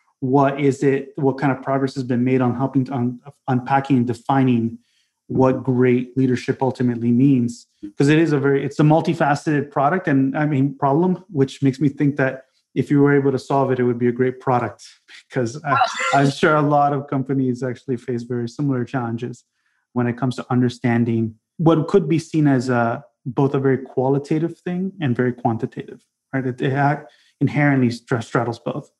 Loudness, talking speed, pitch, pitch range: -20 LUFS, 190 wpm, 135 Hz, 125-140 Hz